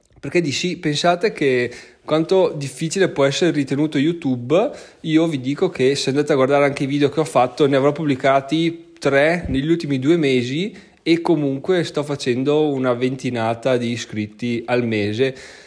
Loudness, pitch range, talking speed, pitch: -19 LUFS, 130-160 Hz, 165 wpm, 140 Hz